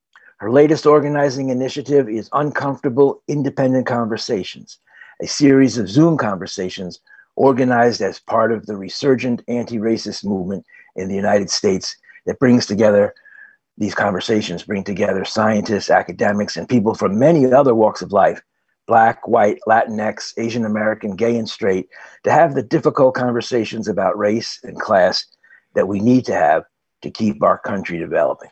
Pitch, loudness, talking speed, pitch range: 115 Hz, -17 LUFS, 145 wpm, 105-135 Hz